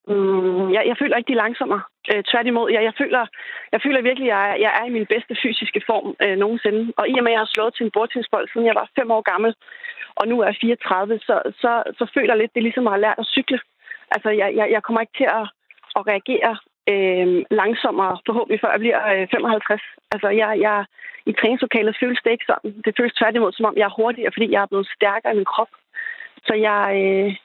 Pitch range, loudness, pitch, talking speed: 210-240 Hz, -20 LUFS, 225 Hz, 245 wpm